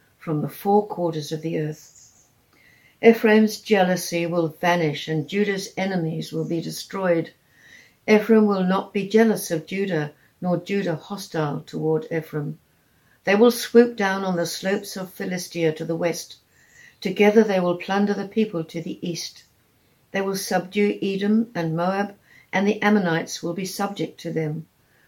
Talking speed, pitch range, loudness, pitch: 155 wpm, 165-200 Hz, -23 LUFS, 180 Hz